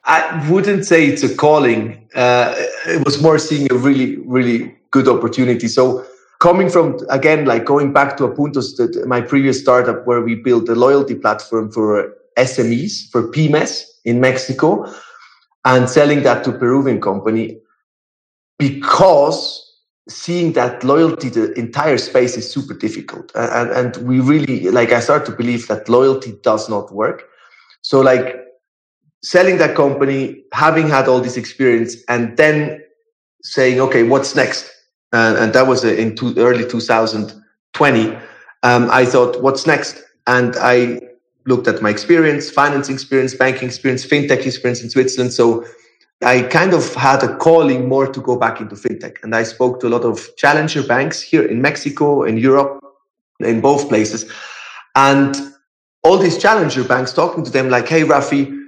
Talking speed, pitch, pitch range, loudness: 155 wpm, 130 Hz, 120-145 Hz, -14 LUFS